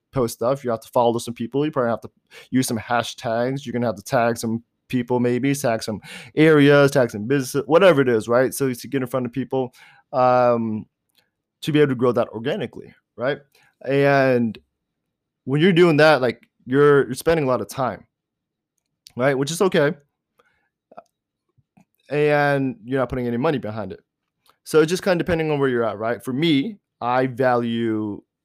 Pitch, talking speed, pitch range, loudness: 130 Hz, 190 wpm, 115-145 Hz, -20 LUFS